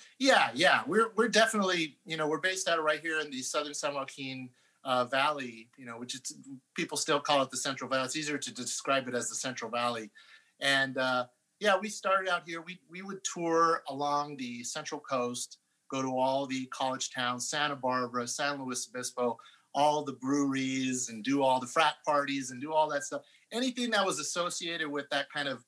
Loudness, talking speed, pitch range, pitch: -31 LUFS, 205 wpm, 130-160 Hz, 140 Hz